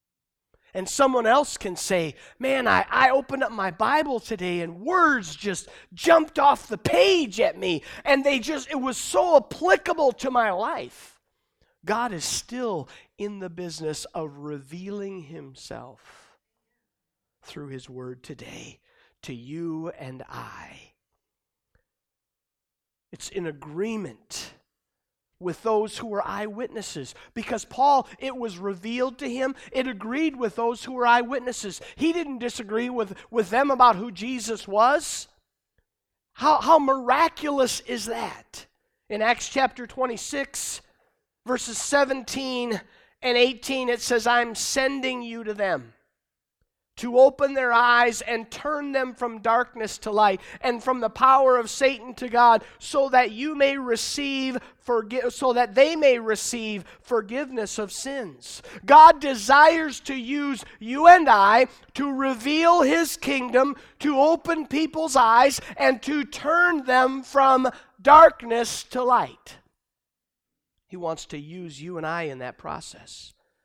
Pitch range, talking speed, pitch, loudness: 215-275 Hz, 135 wpm, 245 Hz, -22 LUFS